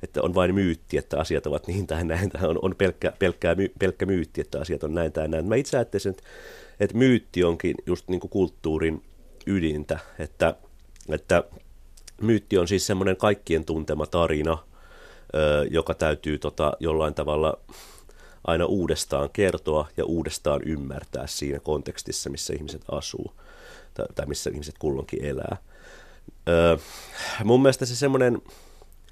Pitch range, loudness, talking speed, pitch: 80-100 Hz, -25 LUFS, 135 wpm, 85 Hz